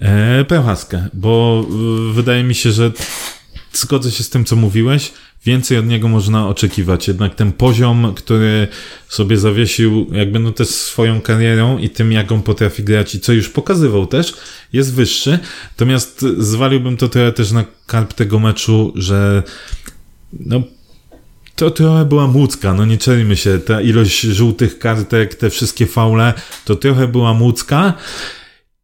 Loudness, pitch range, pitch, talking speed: -14 LUFS, 110-125 Hz, 115 Hz, 150 wpm